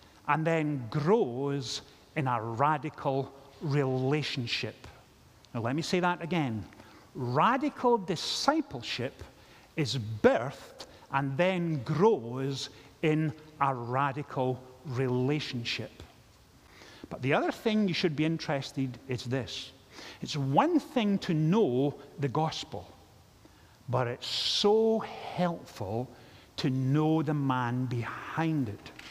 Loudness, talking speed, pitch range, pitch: -30 LUFS, 105 wpm, 125-160 Hz, 140 Hz